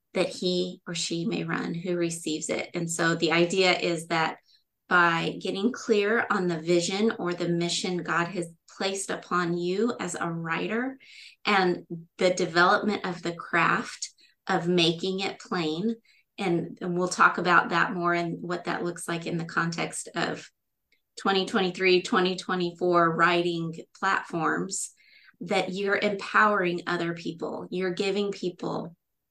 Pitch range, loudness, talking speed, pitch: 170-195 Hz, -26 LUFS, 145 wpm, 180 Hz